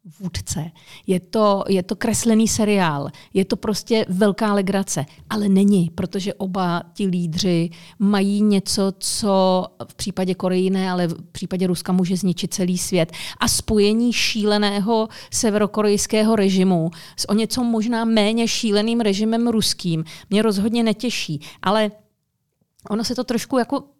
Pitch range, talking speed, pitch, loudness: 180-220 Hz, 135 wpm, 200 Hz, -20 LUFS